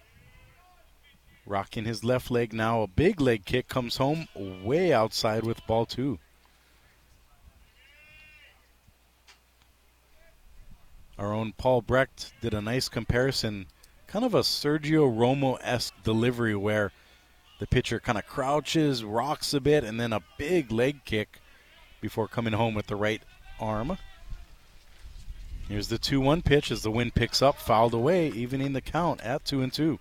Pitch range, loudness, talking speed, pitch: 100-130 Hz, -27 LUFS, 140 wpm, 115 Hz